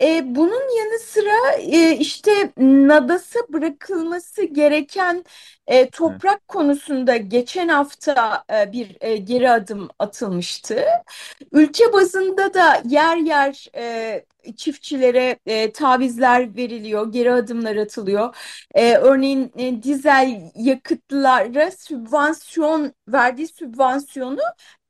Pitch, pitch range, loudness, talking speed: 285 Hz, 250-330 Hz, -18 LUFS, 75 wpm